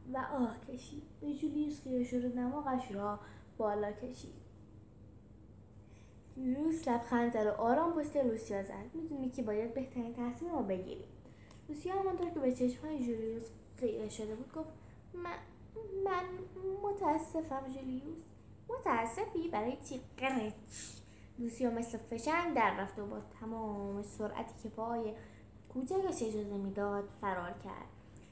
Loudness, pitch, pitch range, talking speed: -38 LUFS, 245 Hz, 210-300 Hz, 125 wpm